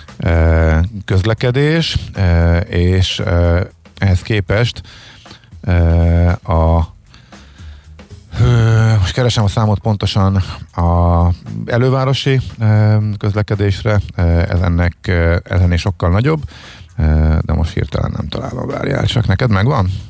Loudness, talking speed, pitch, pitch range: -15 LUFS, 80 wpm, 100 Hz, 85-110 Hz